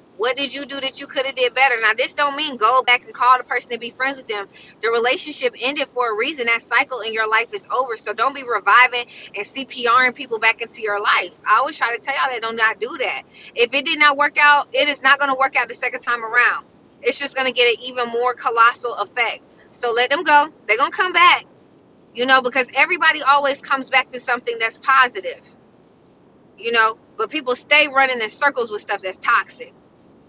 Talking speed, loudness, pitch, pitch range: 230 wpm, -18 LUFS, 255 Hz, 235-280 Hz